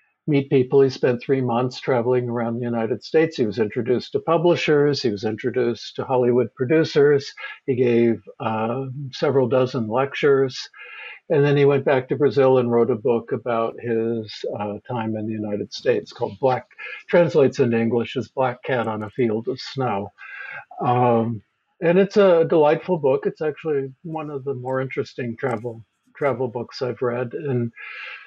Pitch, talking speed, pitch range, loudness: 125 Hz, 170 wpm, 115-140 Hz, -21 LUFS